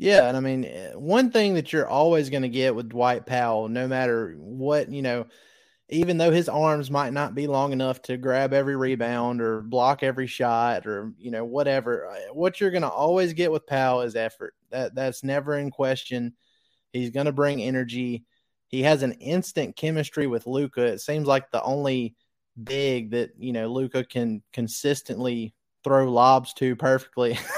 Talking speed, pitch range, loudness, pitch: 175 wpm, 120-145 Hz, -25 LUFS, 130 Hz